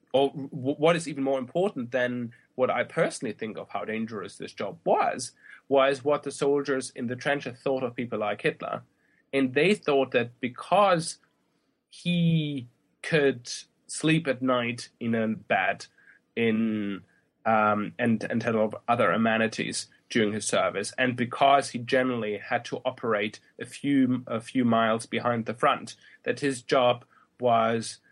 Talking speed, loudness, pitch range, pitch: 150 wpm, -27 LUFS, 115-140 Hz, 125 Hz